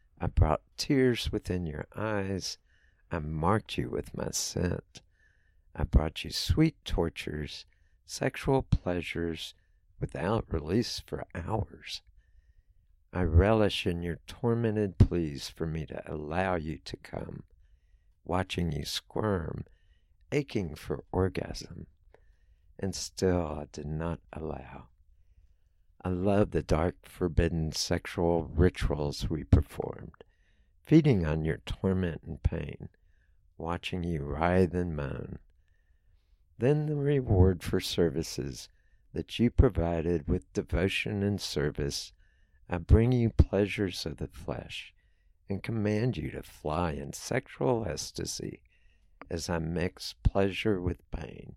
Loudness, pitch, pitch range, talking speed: -31 LUFS, 85 Hz, 80-95 Hz, 120 wpm